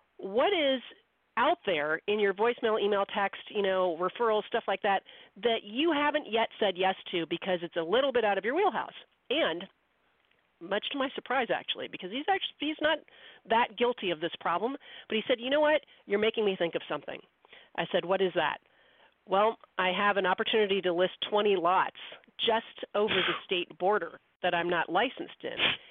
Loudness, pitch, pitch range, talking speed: -29 LUFS, 205 Hz, 185-240 Hz, 190 wpm